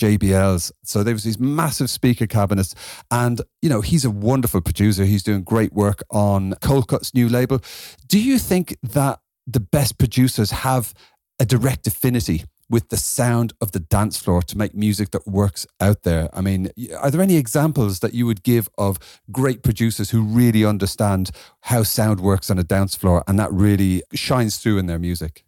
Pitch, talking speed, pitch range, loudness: 110 Hz, 190 wpm, 100-125 Hz, -19 LUFS